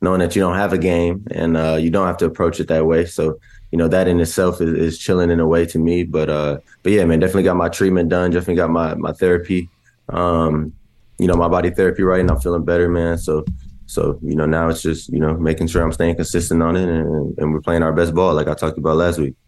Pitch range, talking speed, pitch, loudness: 80-90 Hz, 270 wpm, 85 Hz, -17 LUFS